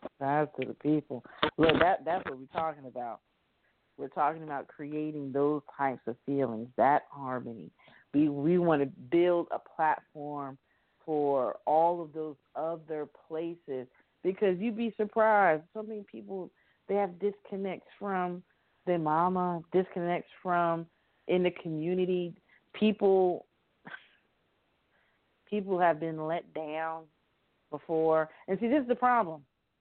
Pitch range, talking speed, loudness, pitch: 145-185 Hz, 125 wpm, -31 LUFS, 165 Hz